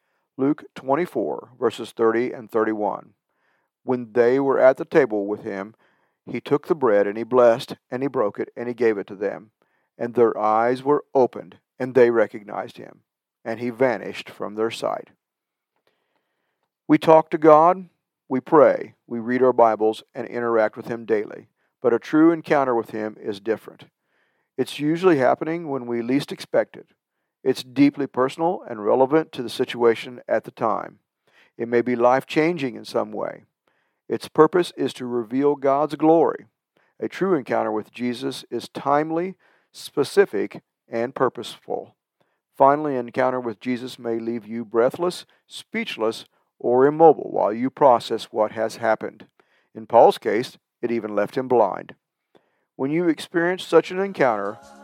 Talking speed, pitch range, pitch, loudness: 160 wpm, 115-150 Hz, 125 Hz, -22 LUFS